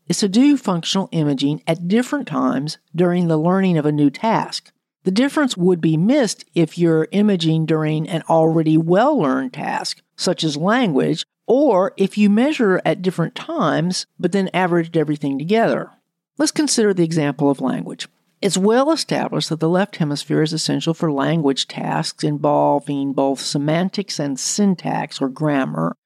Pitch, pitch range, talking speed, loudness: 165 Hz, 150-200 Hz, 155 wpm, -18 LUFS